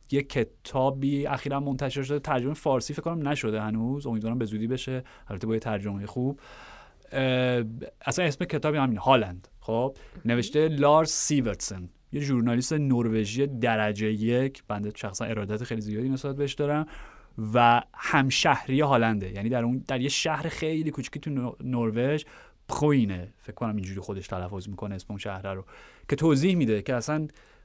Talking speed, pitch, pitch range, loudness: 155 wpm, 125 Hz, 110-140 Hz, -27 LUFS